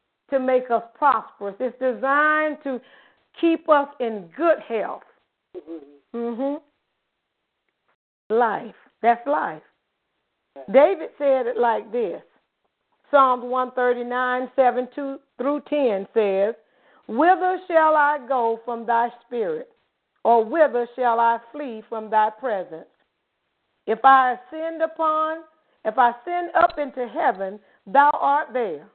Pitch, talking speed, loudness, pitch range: 255 Hz, 120 wpm, -22 LUFS, 235-295 Hz